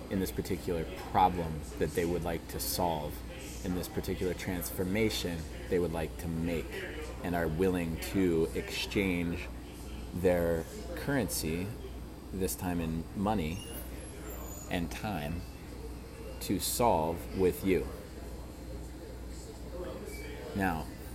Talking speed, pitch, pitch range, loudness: 105 wpm, 80 Hz, 75-90 Hz, -34 LUFS